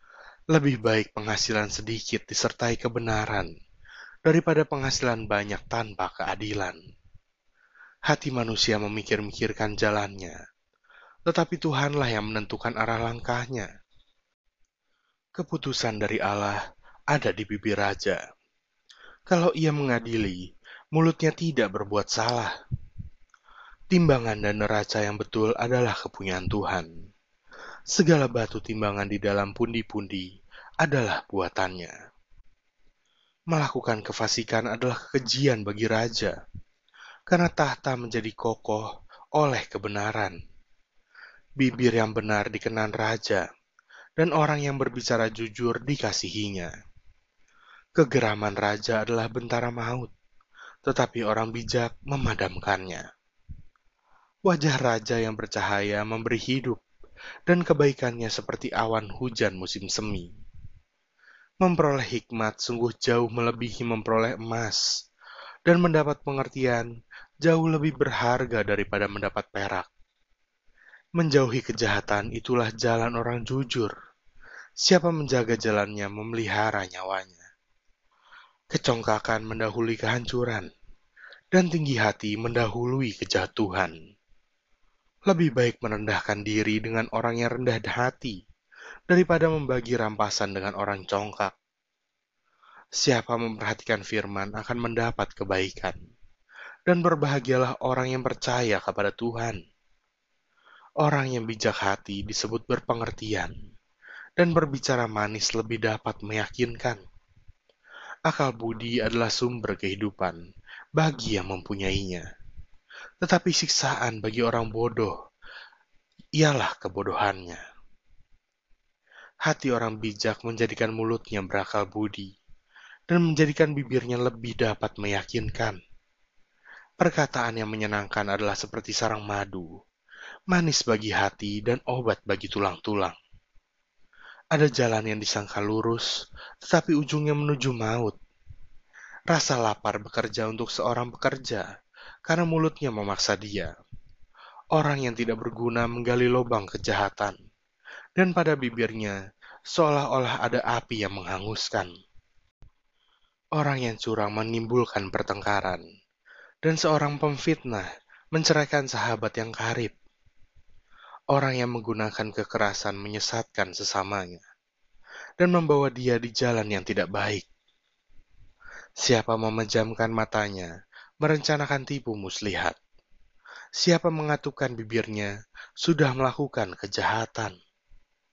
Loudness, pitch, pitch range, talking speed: -27 LUFS, 115 Hz, 105-130 Hz, 95 wpm